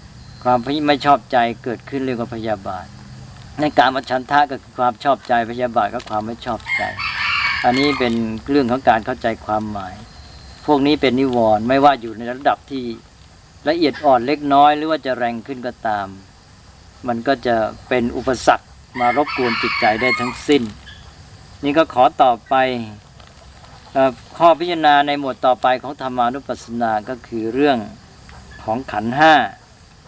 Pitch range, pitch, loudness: 115-140 Hz, 125 Hz, -18 LUFS